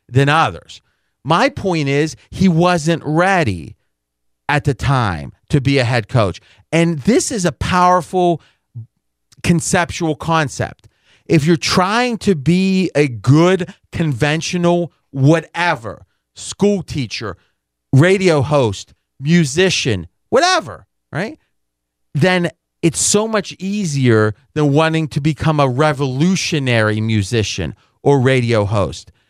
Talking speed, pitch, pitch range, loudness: 110 wpm, 150 Hz, 115-175 Hz, -16 LUFS